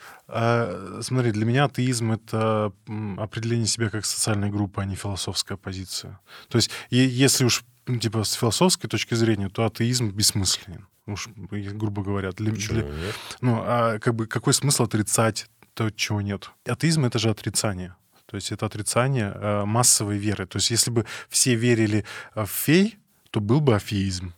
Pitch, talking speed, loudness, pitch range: 110 Hz, 155 wpm, -24 LUFS, 100-120 Hz